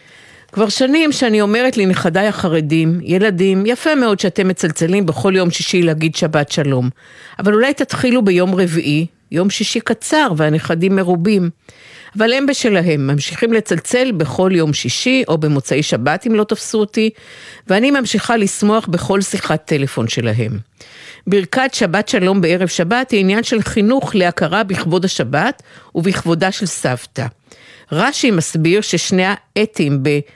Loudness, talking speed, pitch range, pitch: -15 LUFS, 135 wpm, 165-220 Hz, 190 Hz